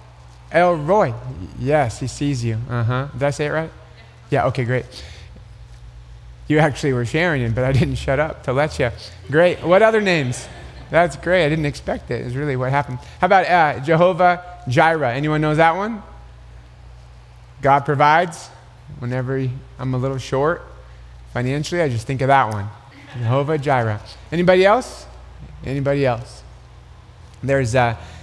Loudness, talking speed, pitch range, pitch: -19 LUFS, 160 wpm, 115-150 Hz, 130 Hz